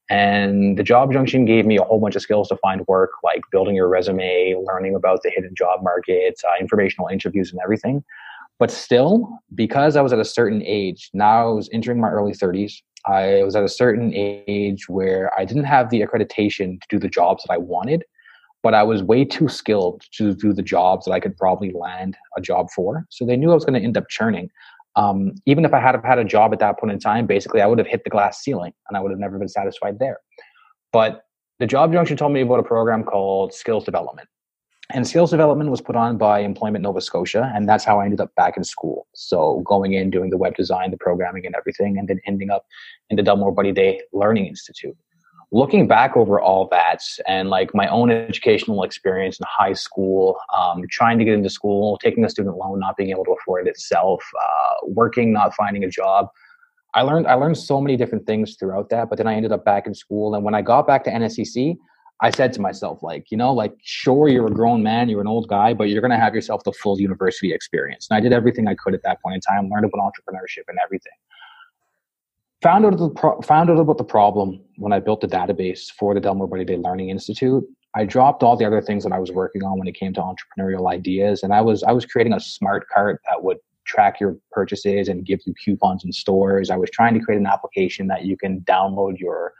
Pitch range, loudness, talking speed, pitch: 95-135 Hz, -19 LUFS, 235 wpm, 105 Hz